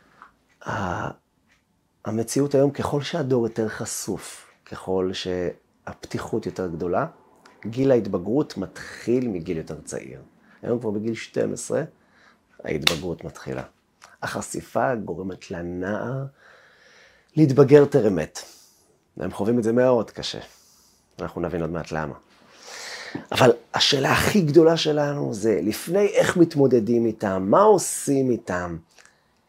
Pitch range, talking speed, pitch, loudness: 90-135 Hz, 105 wpm, 115 Hz, -23 LUFS